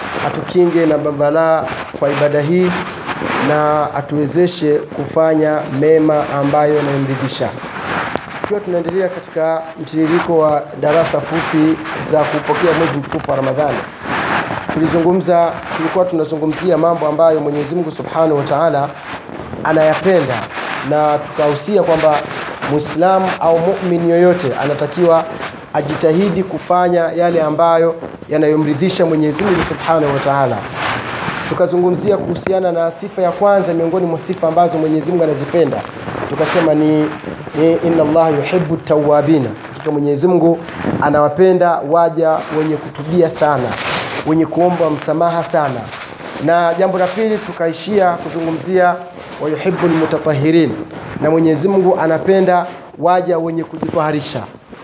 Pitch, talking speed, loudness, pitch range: 160 Hz, 105 wpm, -15 LUFS, 150-175 Hz